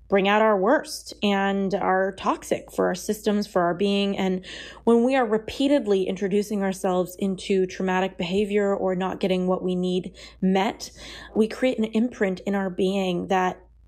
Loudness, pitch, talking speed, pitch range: -24 LUFS, 195 Hz, 165 wpm, 185-210 Hz